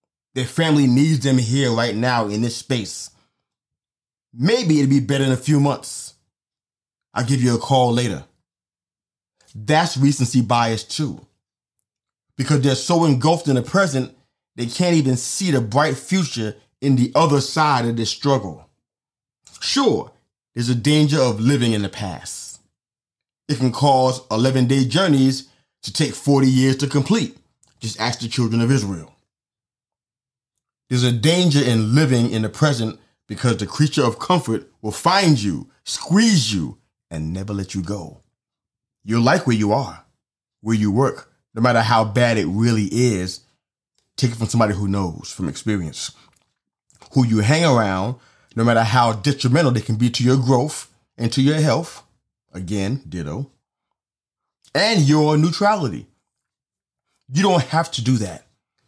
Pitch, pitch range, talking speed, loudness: 130 Hz, 115-145 Hz, 155 wpm, -19 LUFS